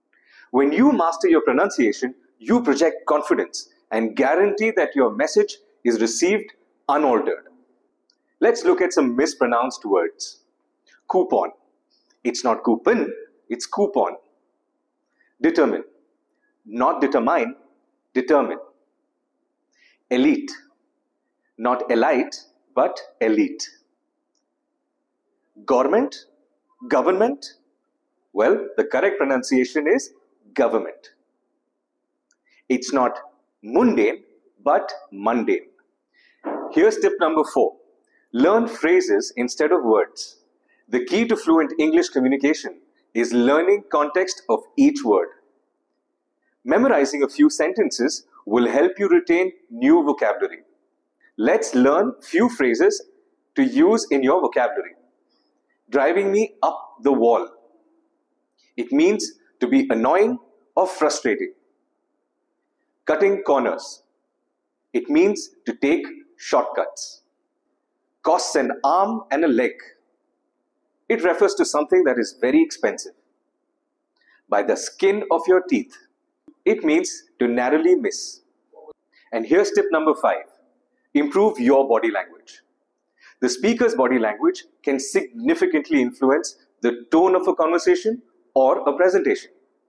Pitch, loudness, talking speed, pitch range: 325 Hz, -20 LUFS, 105 wpm, 230-380 Hz